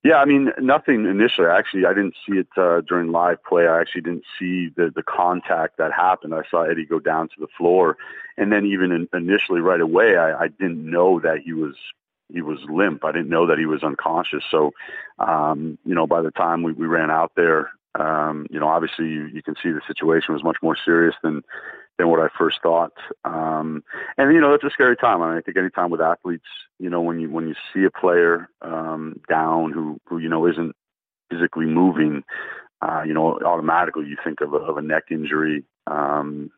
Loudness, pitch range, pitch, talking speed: -20 LUFS, 80-85 Hz, 80 Hz, 225 wpm